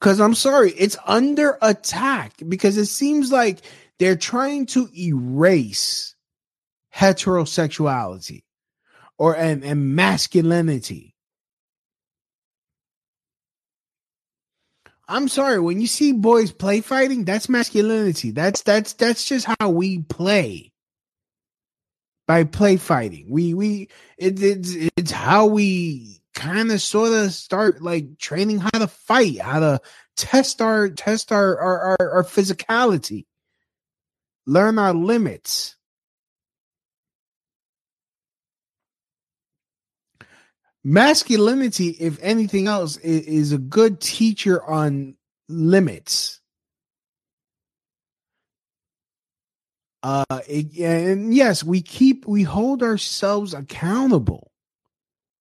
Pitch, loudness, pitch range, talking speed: 195 Hz, -19 LUFS, 165-220 Hz, 95 wpm